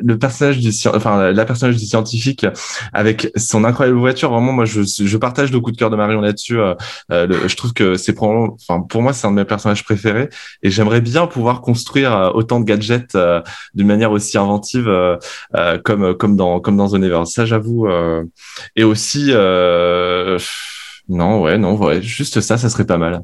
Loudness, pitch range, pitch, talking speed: -15 LUFS, 100-120 Hz, 110 Hz, 200 wpm